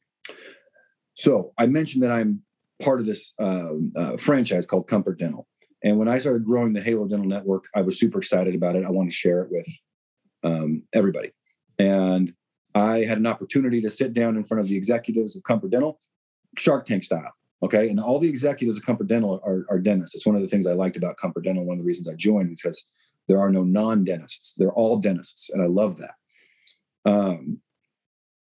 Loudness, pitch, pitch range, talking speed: -23 LUFS, 105 Hz, 95-115 Hz, 205 wpm